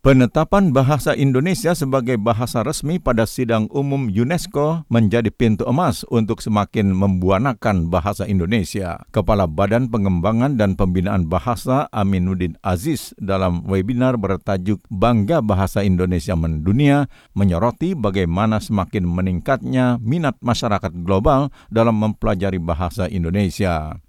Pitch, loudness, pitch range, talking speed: 105 Hz, -19 LUFS, 95-125 Hz, 110 wpm